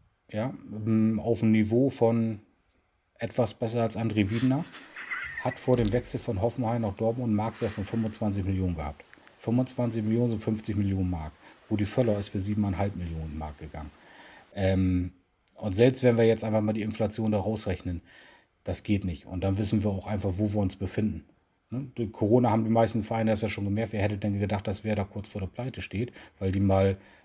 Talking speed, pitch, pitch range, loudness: 200 wpm, 105 Hz, 95-115 Hz, -28 LUFS